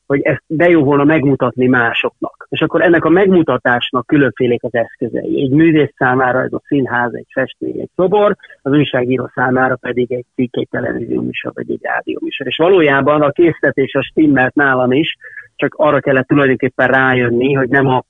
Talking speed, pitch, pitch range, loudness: 180 wpm, 135 Hz, 125-155 Hz, -14 LUFS